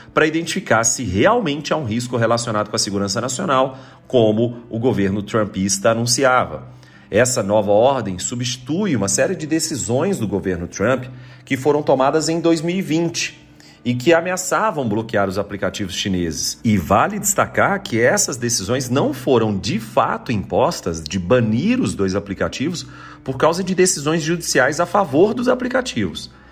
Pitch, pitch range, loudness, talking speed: 125 Hz, 105-155 Hz, -18 LUFS, 145 wpm